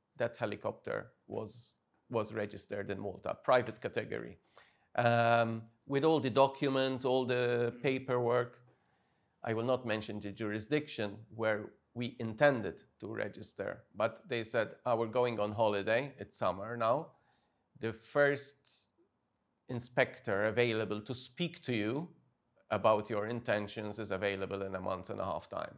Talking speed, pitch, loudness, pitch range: 135 wpm, 115 Hz, -35 LUFS, 105-130 Hz